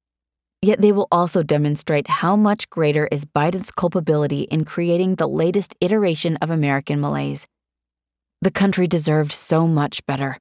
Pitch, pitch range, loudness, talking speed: 155 Hz, 140-180 Hz, -19 LUFS, 145 wpm